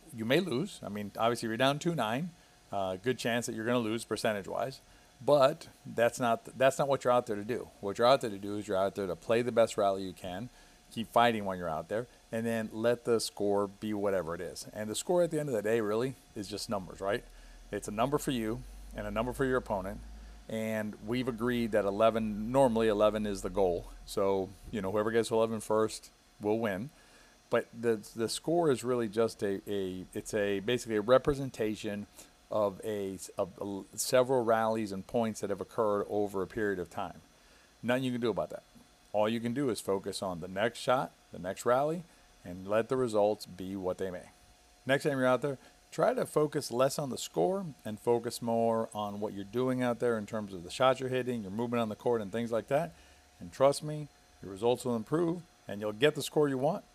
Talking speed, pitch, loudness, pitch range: 225 wpm, 115 Hz, -32 LUFS, 100-125 Hz